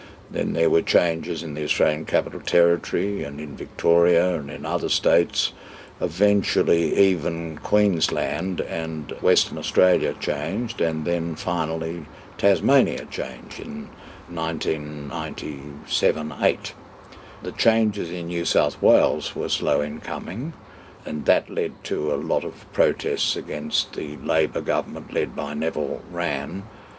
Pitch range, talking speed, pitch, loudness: 80-100 Hz, 125 wpm, 85 Hz, -23 LUFS